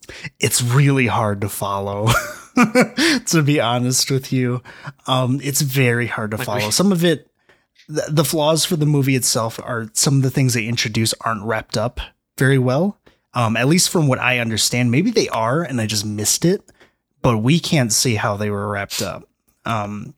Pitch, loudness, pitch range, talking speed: 125 Hz, -18 LUFS, 115-150 Hz, 185 wpm